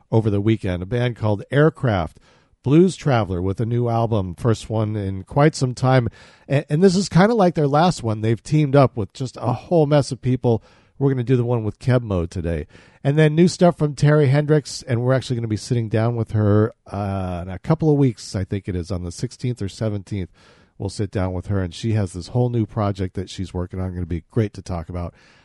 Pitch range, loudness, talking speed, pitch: 95-135 Hz, -21 LUFS, 240 wpm, 115 Hz